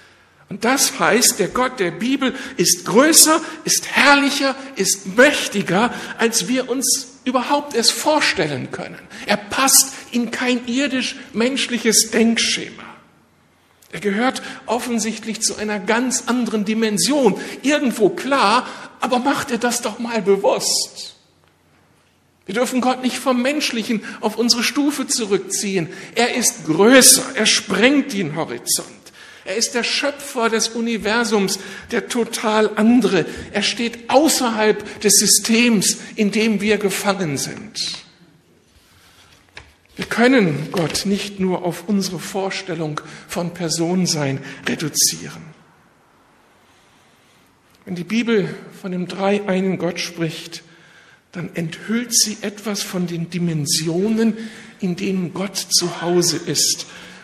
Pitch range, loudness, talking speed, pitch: 185-245 Hz, -17 LUFS, 115 wpm, 220 Hz